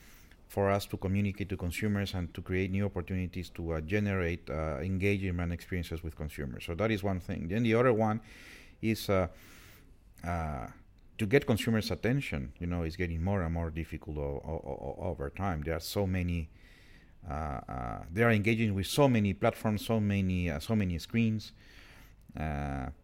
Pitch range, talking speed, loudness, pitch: 80-105 Hz, 175 wpm, -33 LUFS, 95 Hz